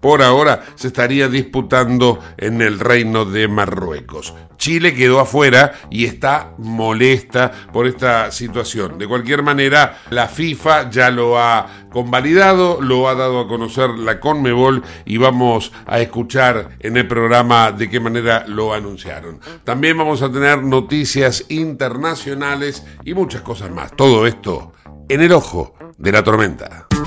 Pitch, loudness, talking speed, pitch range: 120 Hz, -14 LUFS, 145 wpm, 110-135 Hz